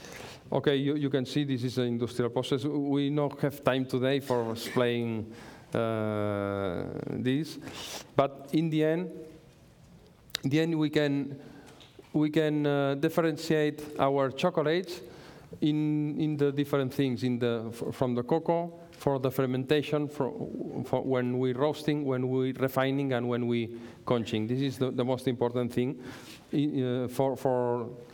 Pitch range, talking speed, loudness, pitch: 125-150 Hz, 155 wpm, -30 LUFS, 135 Hz